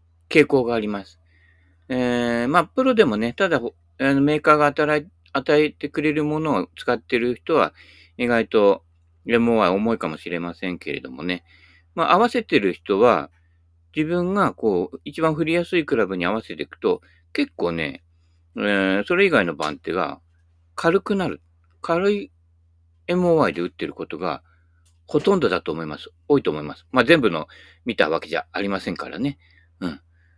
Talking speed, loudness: 320 characters per minute, -21 LUFS